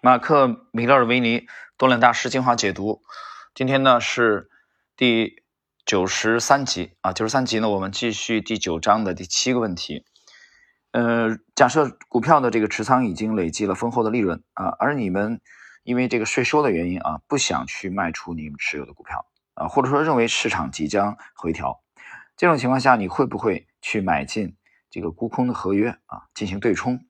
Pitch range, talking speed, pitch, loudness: 100-125 Hz, 275 characters per minute, 115 Hz, -21 LUFS